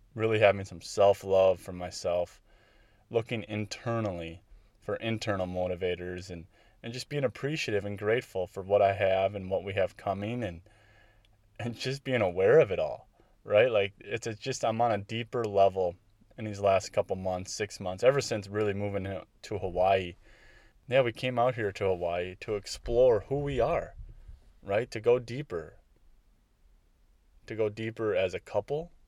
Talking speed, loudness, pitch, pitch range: 165 wpm, -30 LUFS, 105 Hz, 95-115 Hz